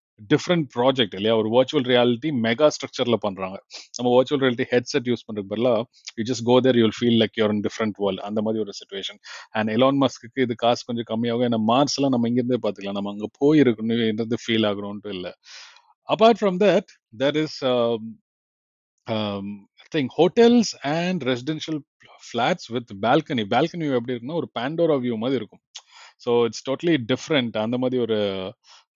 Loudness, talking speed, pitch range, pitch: -22 LUFS, 120 wpm, 110-140 Hz, 120 Hz